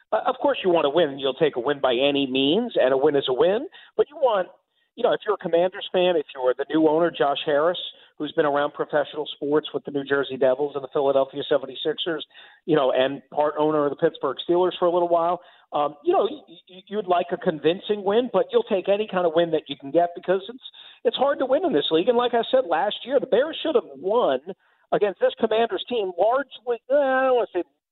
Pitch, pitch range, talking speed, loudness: 175 Hz, 150-240 Hz, 240 wpm, -23 LUFS